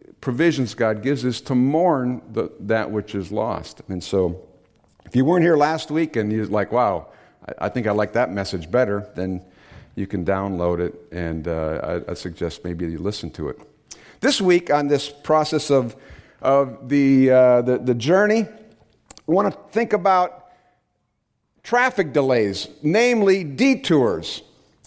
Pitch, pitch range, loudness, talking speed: 125 Hz, 100-155 Hz, -21 LUFS, 160 wpm